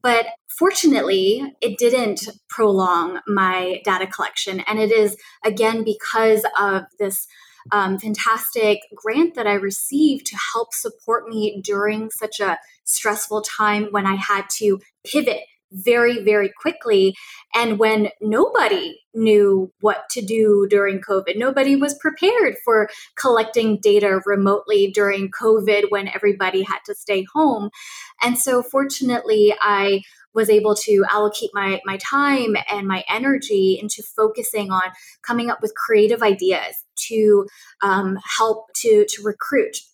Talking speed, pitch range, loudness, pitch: 135 wpm, 200-240 Hz, -19 LUFS, 215 Hz